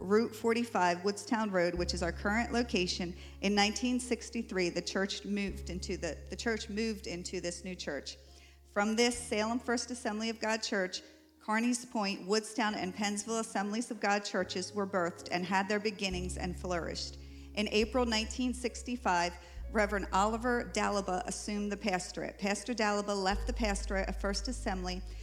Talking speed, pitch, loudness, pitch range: 155 wpm, 205 Hz, -34 LUFS, 185-225 Hz